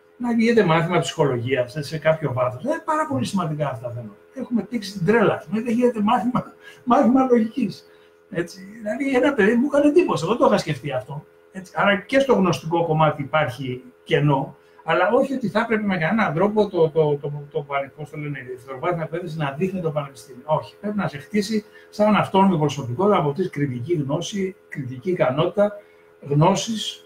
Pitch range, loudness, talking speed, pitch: 145-210 Hz, -21 LUFS, 175 wpm, 170 Hz